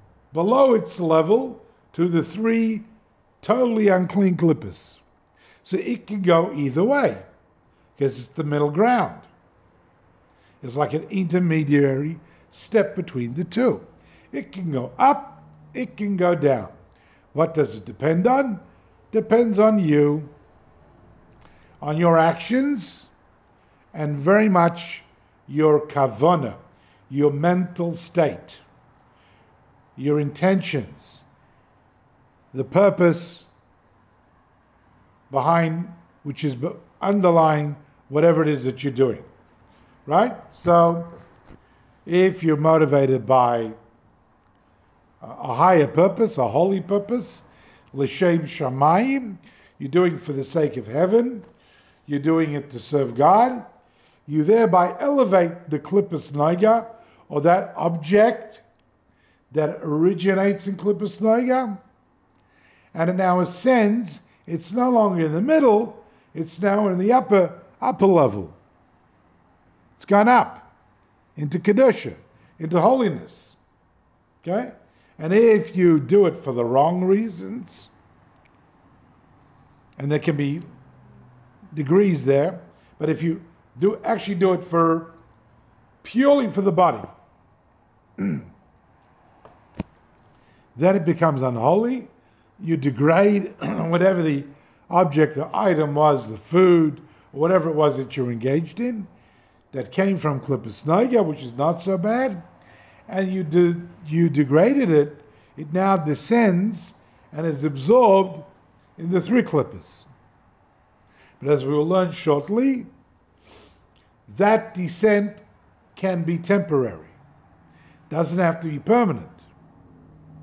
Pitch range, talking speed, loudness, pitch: 135-195 Hz, 115 wpm, -20 LUFS, 165 Hz